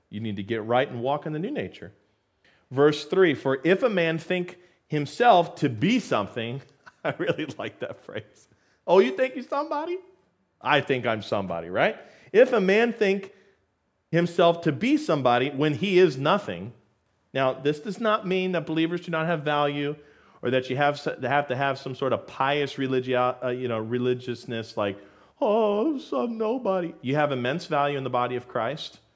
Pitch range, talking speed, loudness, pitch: 125-185 Hz, 180 wpm, -25 LUFS, 145 Hz